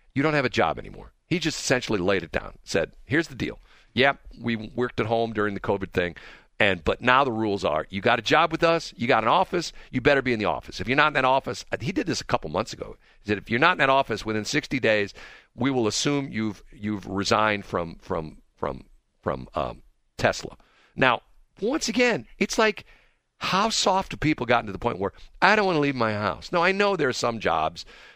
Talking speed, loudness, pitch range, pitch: 240 wpm, -24 LUFS, 105-150 Hz, 120 Hz